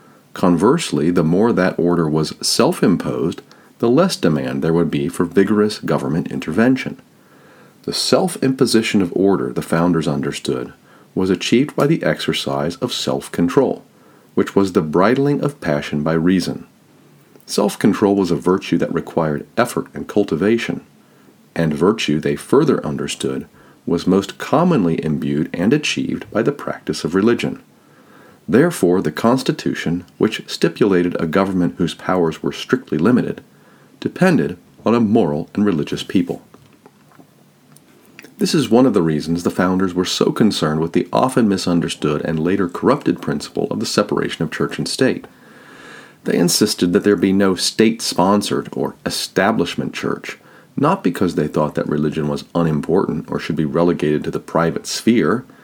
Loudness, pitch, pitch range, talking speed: -18 LUFS, 85 Hz, 75-95 Hz, 145 wpm